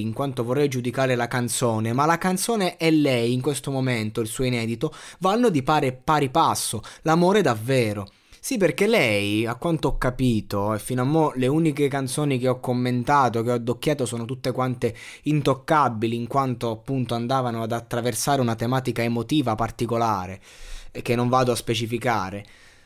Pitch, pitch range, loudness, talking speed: 125 Hz, 115-145 Hz, -23 LUFS, 170 wpm